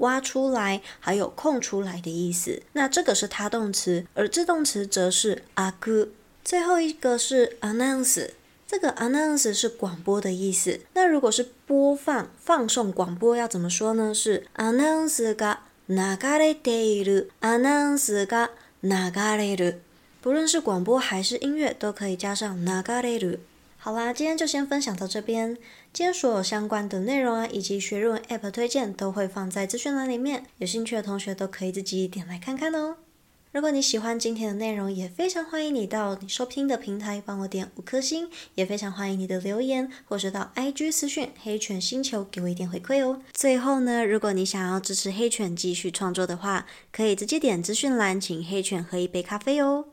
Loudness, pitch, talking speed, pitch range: -26 LUFS, 220 Hz, 320 characters per minute, 195-265 Hz